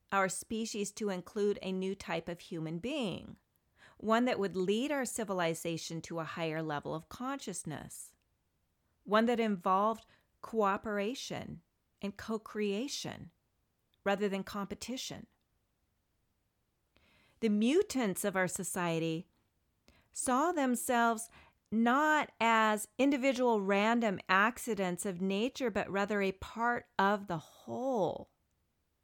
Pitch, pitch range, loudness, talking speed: 200 Hz, 175-230 Hz, -34 LUFS, 110 wpm